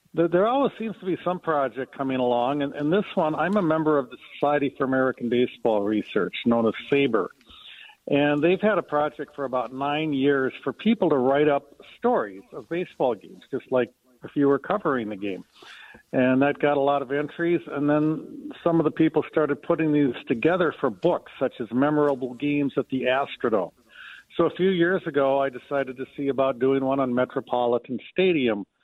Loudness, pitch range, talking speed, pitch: -24 LUFS, 130-160 Hz, 195 wpm, 140 Hz